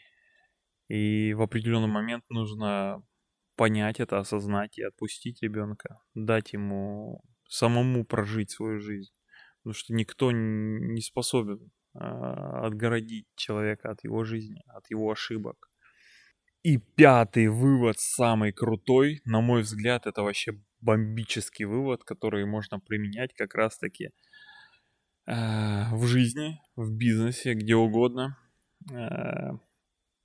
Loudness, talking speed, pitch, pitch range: -28 LUFS, 110 wpm, 110 Hz, 105-120 Hz